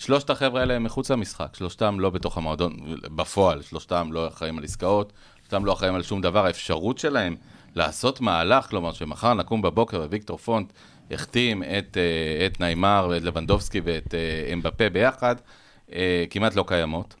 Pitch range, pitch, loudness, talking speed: 85-110 Hz, 95 Hz, -25 LUFS, 155 wpm